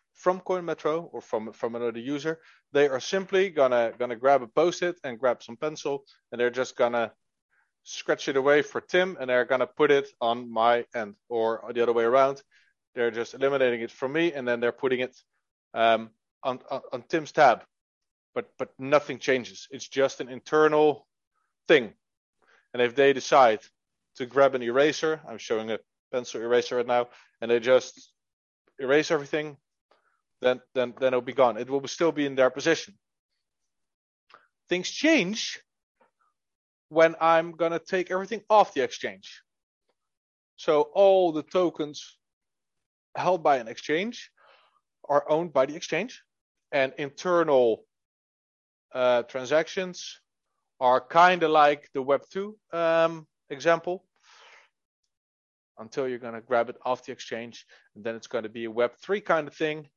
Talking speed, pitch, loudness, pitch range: 155 wpm, 140 Hz, -26 LUFS, 120-165 Hz